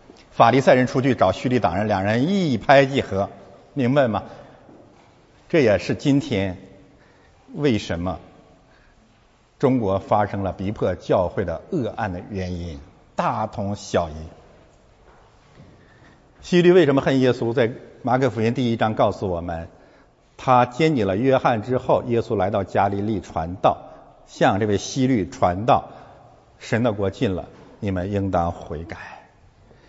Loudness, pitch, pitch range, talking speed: -21 LUFS, 105 Hz, 95-125 Hz, 205 characters per minute